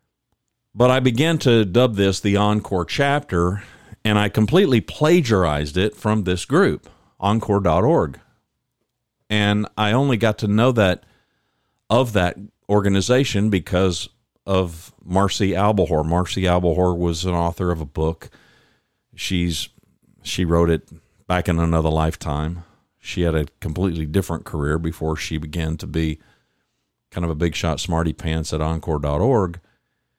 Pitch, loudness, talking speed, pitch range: 95 Hz, -20 LUFS, 135 wpm, 85-110 Hz